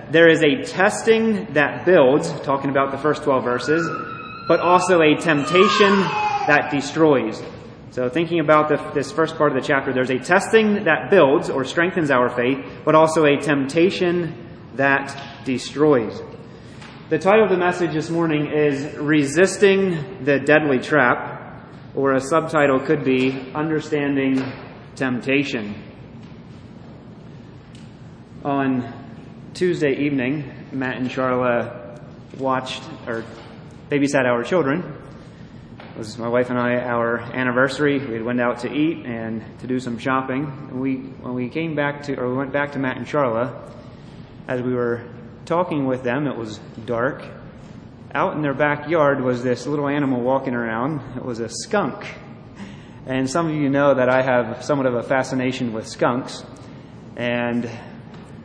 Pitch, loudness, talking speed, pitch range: 135 Hz, -20 LUFS, 150 wpm, 125-150 Hz